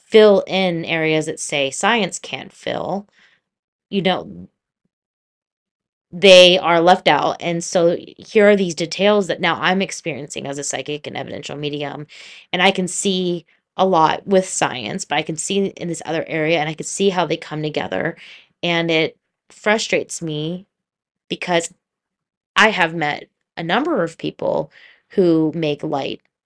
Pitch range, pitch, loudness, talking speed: 155-190 Hz, 170 Hz, -18 LUFS, 155 wpm